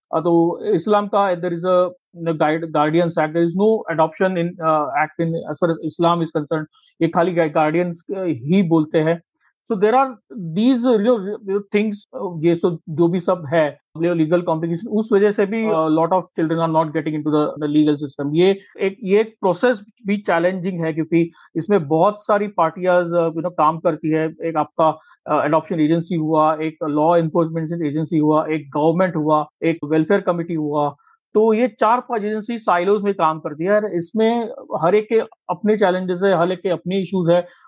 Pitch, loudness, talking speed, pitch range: 170 Hz, -19 LUFS, 130 wpm, 160-200 Hz